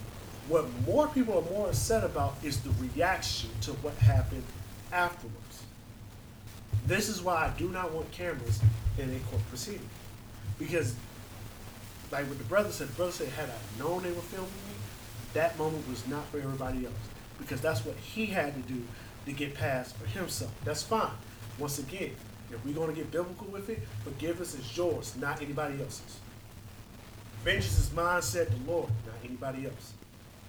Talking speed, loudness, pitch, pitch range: 175 wpm, -33 LUFS, 120 Hz, 110-150 Hz